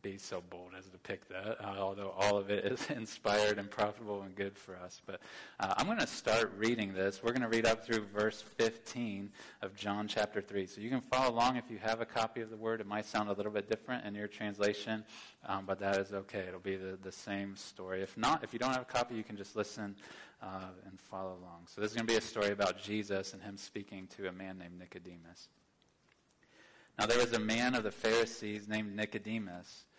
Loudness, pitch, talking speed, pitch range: -37 LUFS, 105 Hz, 240 wpm, 95-110 Hz